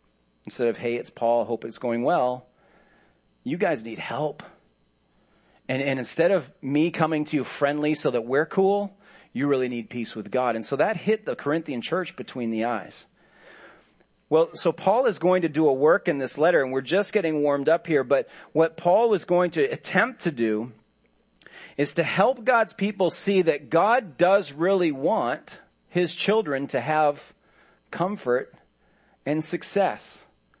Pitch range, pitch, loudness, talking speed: 125-185 Hz, 155 Hz, -24 LUFS, 175 wpm